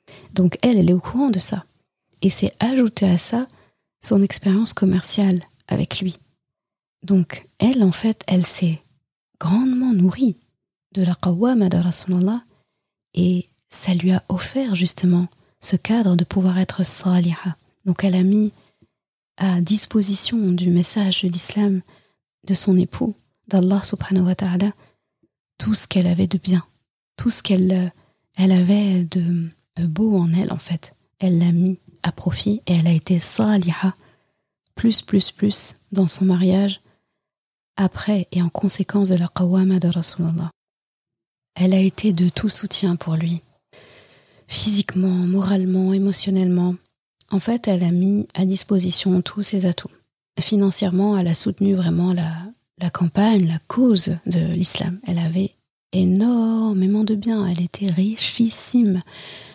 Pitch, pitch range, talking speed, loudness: 185 Hz, 175-200 Hz, 145 wpm, -19 LUFS